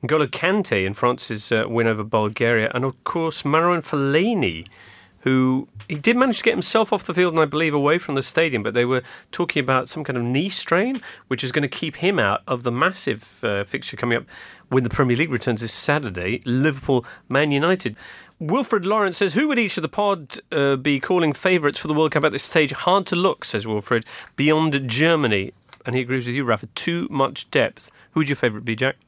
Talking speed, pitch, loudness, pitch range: 215 wpm, 140 Hz, -21 LUFS, 125-165 Hz